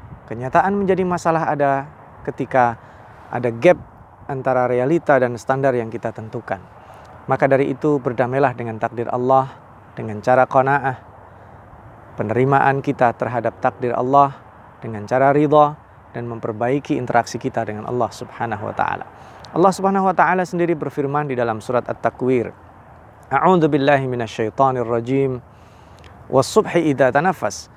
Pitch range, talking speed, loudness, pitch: 115-140 Hz, 120 wpm, -19 LUFS, 125 Hz